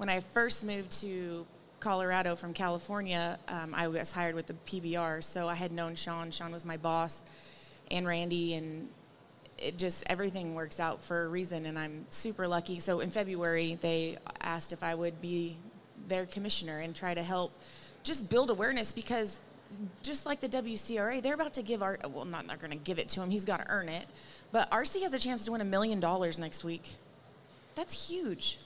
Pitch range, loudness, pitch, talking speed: 165-205 Hz, -34 LUFS, 175 Hz, 200 wpm